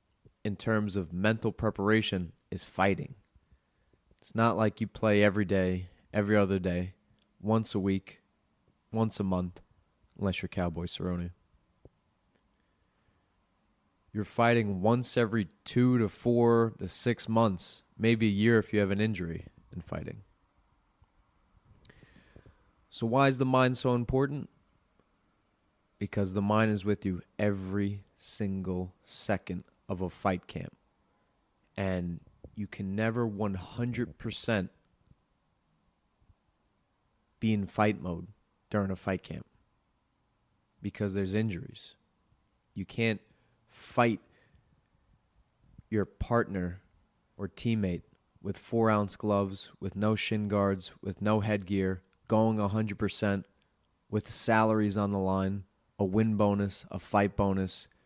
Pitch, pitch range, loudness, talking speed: 100 Hz, 95-110 Hz, -31 LUFS, 120 wpm